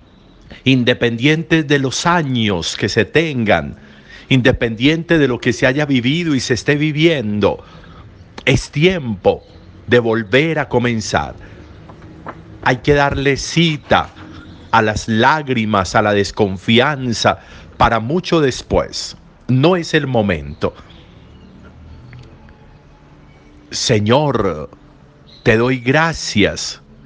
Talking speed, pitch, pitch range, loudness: 100 wpm, 125 Hz, 105-150 Hz, -15 LUFS